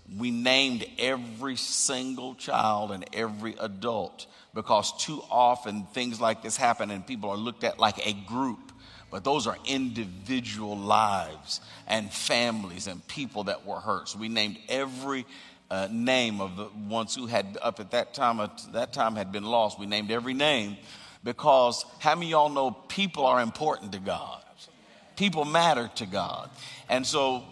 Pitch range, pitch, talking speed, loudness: 105-130 Hz, 120 Hz, 170 wpm, -28 LUFS